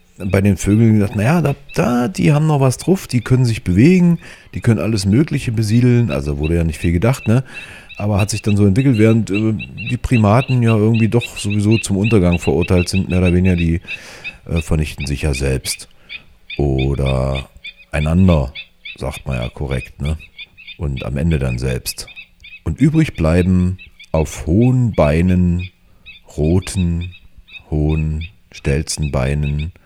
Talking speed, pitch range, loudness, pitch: 155 wpm, 80-115 Hz, -16 LUFS, 90 Hz